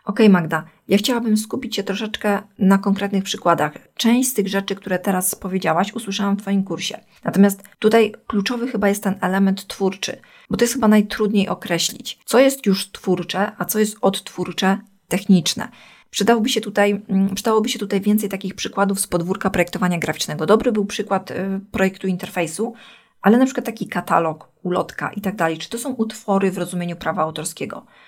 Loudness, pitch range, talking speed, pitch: -20 LUFS, 185-215 Hz, 165 wpm, 200 Hz